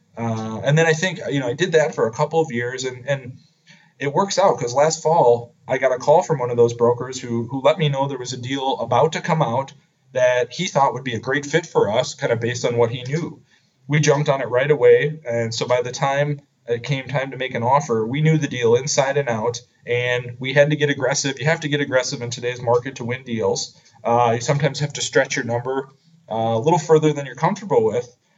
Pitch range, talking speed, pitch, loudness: 120-155 Hz, 255 wpm, 135 Hz, -20 LUFS